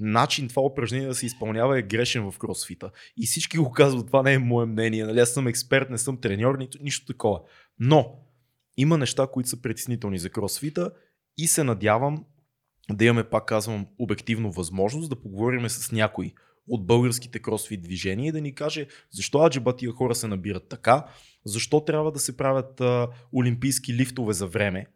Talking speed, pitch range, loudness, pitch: 175 wpm, 110-135 Hz, -25 LUFS, 125 Hz